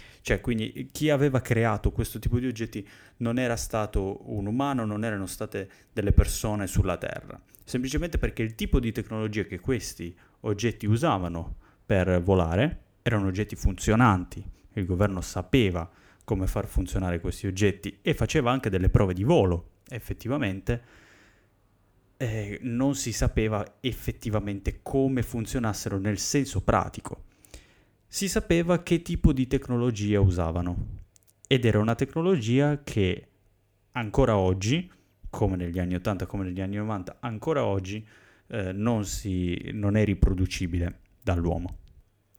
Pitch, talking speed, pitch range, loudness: 105 Hz, 130 wpm, 95-120 Hz, -27 LUFS